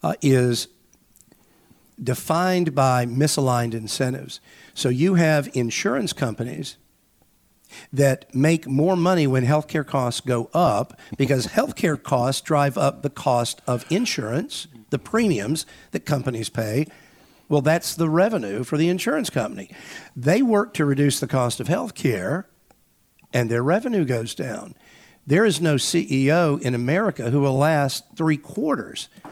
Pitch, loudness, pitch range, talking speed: 145 Hz, -22 LUFS, 125-165 Hz, 135 wpm